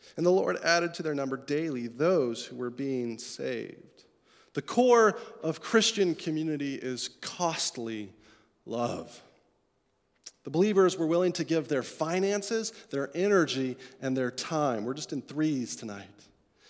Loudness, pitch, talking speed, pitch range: -29 LUFS, 155 Hz, 140 wpm, 125-180 Hz